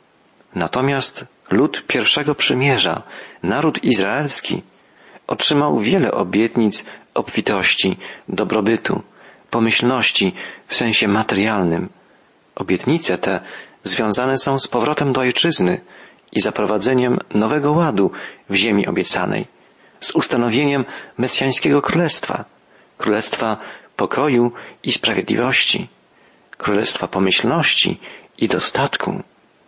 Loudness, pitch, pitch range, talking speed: -17 LUFS, 125 Hz, 105-135 Hz, 85 wpm